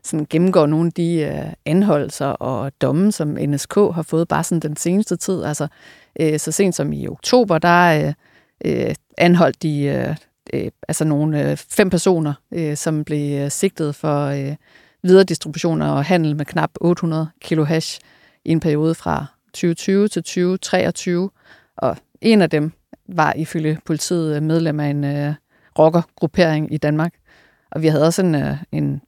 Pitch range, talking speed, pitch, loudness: 150-175 Hz, 165 wpm, 160 Hz, -19 LUFS